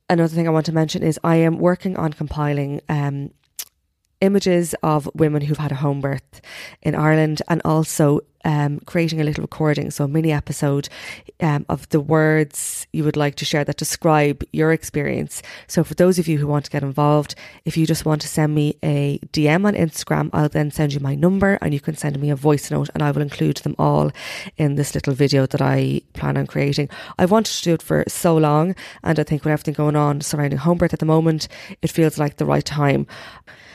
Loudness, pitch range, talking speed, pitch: -20 LUFS, 145-160 Hz, 220 wpm, 150 Hz